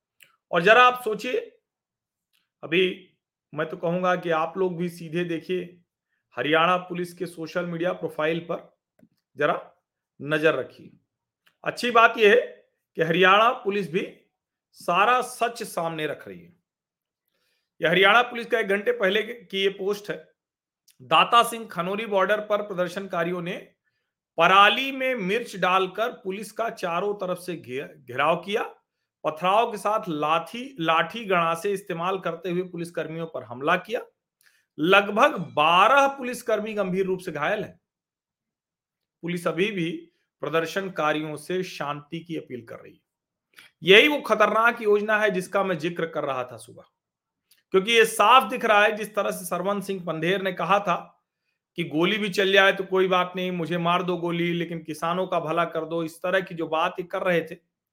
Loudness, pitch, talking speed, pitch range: -23 LUFS, 185 Hz, 160 wpm, 170-210 Hz